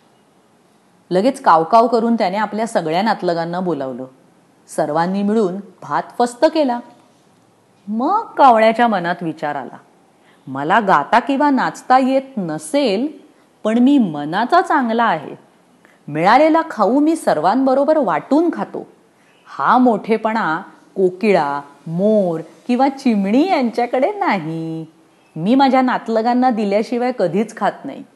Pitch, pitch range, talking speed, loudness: 225 Hz, 180-270 Hz, 105 wpm, -16 LUFS